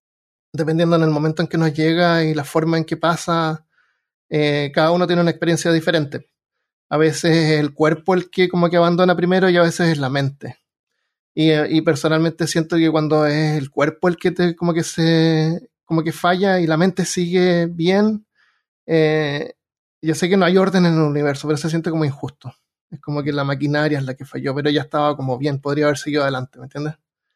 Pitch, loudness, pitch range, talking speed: 160 Hz, -18 LUFS, 150-170 Hz, 210 wpm